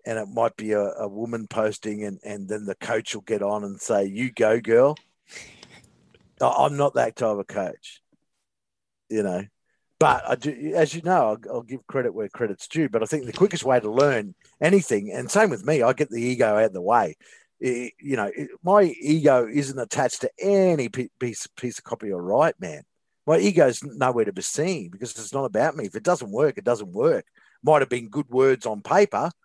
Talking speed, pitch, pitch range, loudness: 215 wpm, 125 Hz, 110-155 Hz, -23 LUFS